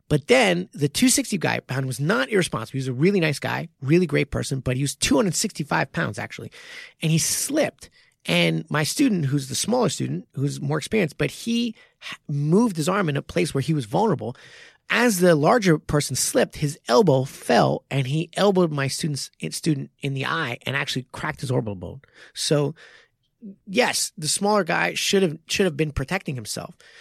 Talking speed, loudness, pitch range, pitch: 185 wpm, -22 LUFS, 140-195 Hz, 155 Hz